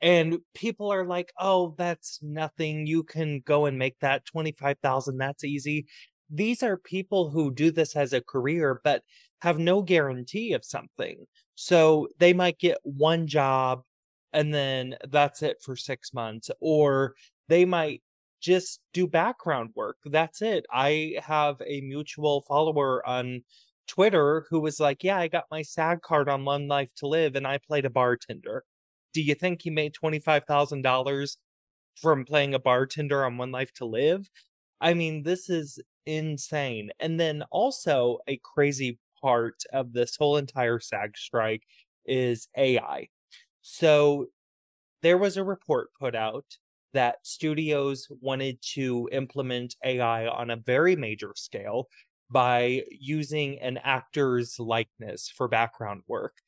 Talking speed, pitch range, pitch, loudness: 150 wpm, 130-165 Hz, 145 Hz, -27 LUFS